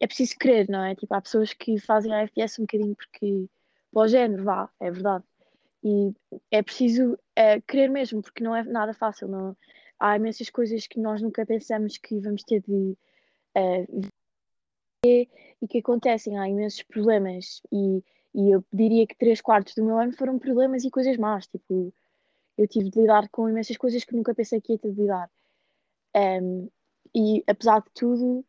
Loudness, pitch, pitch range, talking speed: -25 LUFS, 220 Hz, 200-235 Hz, 185 wpm